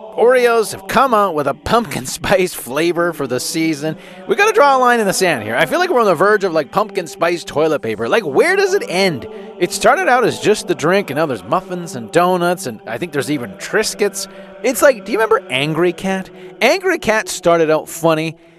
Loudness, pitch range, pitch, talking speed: -15 LUFS, 165-215 Hz, 185 Hz, 230 wpm